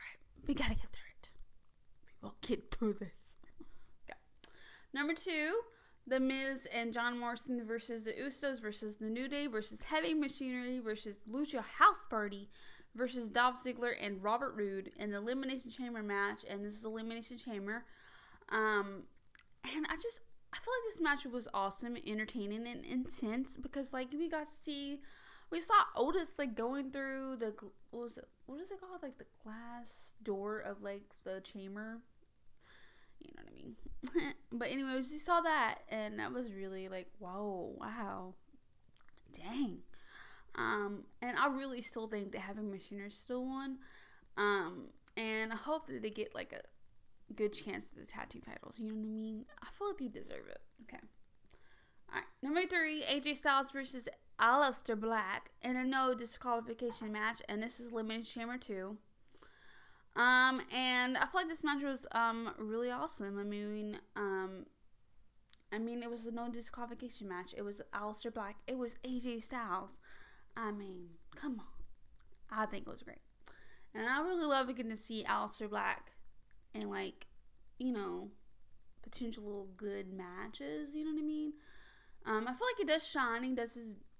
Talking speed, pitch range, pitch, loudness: 170 wpm, 215-275 Hz, 240 Hz, -39 LUFS